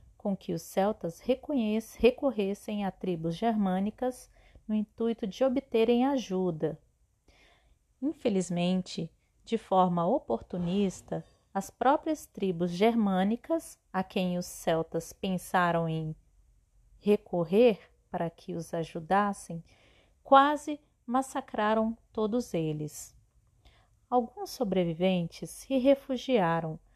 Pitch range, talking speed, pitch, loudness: 175-245 Hz, 90 wpm, 200 Hz, -30 LUFS